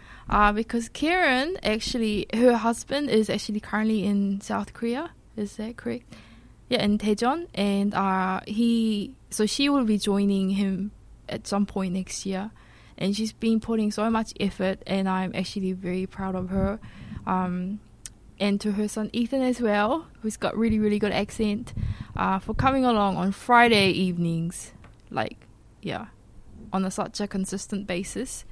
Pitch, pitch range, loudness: 205 Hz, 190-225 Hz, -26 LUFS